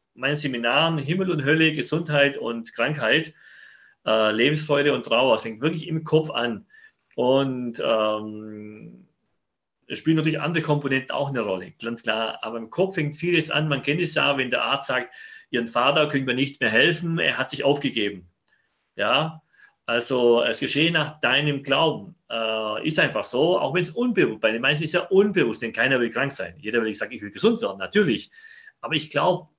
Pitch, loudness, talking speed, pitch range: 145 Hz, -23 LUFS, 190 wpm, 120-165 Hz